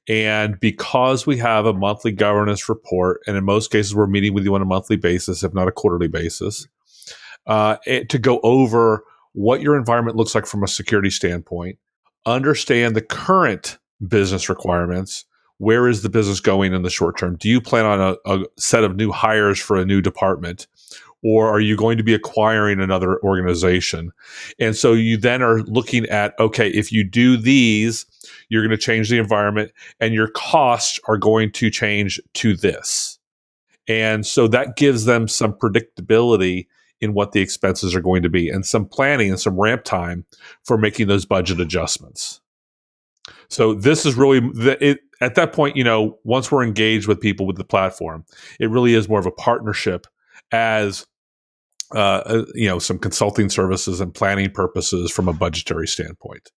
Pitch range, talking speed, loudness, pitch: 95-115 Hz, 180 wpm, -18 LUFS, 105 Hz